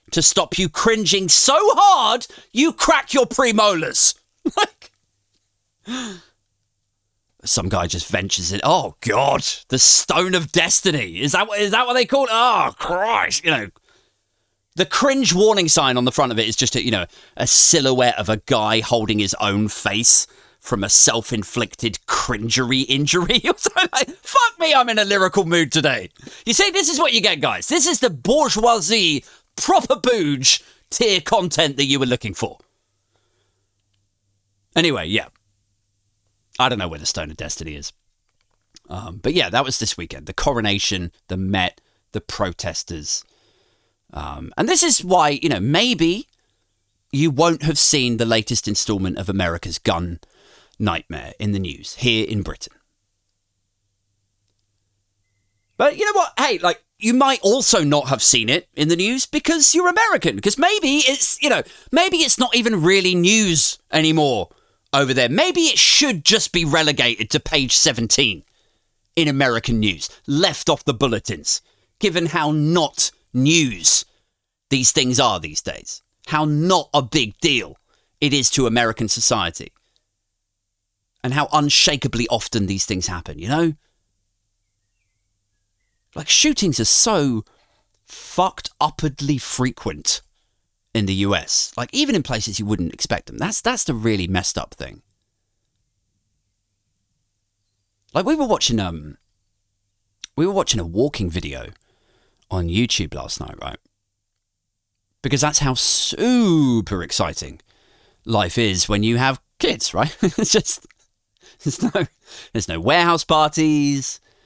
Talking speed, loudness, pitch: 145 wpm, -17 LUFS, 120 Hz